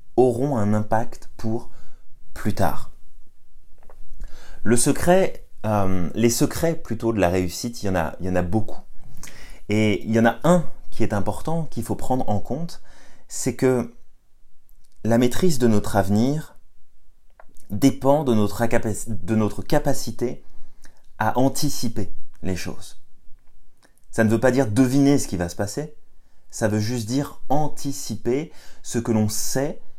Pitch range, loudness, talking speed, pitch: 100-130 Hz, -23 LUFS, 150 wpm, 115 Hz